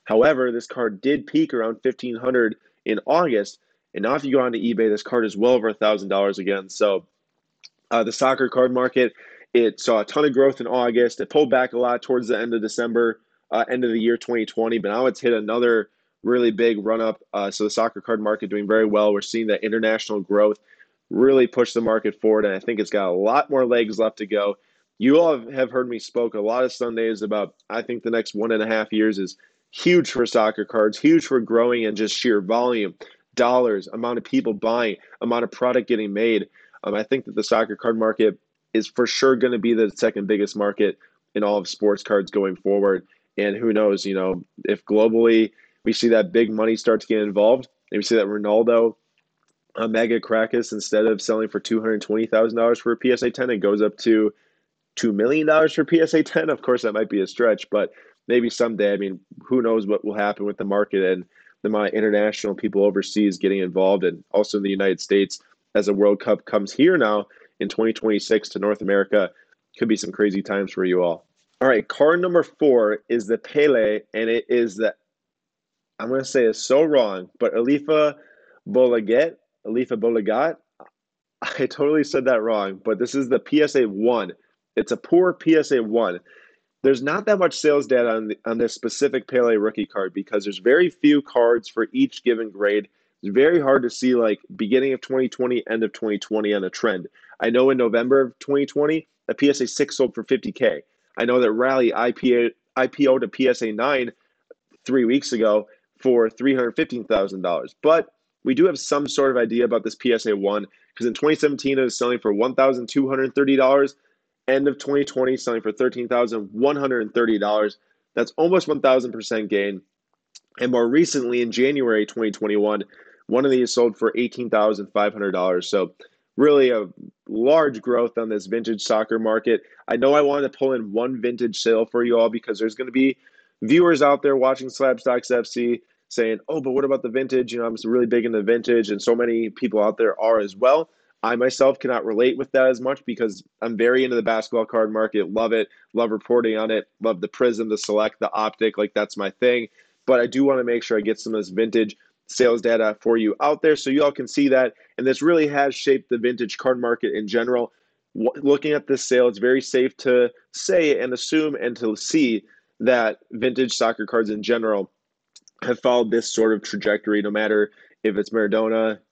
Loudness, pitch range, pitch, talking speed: -21 LUFS, 110-130 Hz, 115 Hz, 205 wpm